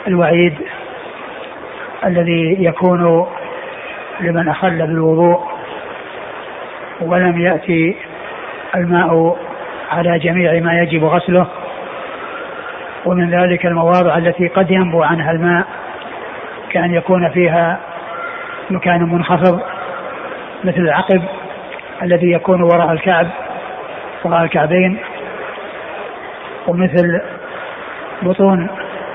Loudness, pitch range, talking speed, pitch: -15 LUFS, 170-185 Hz, 75 wpm, 175 Hz